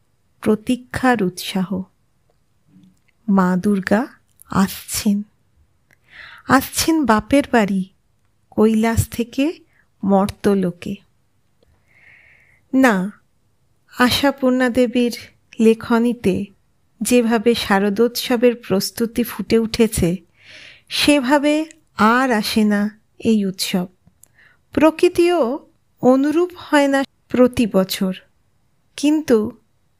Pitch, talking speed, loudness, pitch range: 230 Hz, 65 wpm, -18 LUFS, 200-255 Hz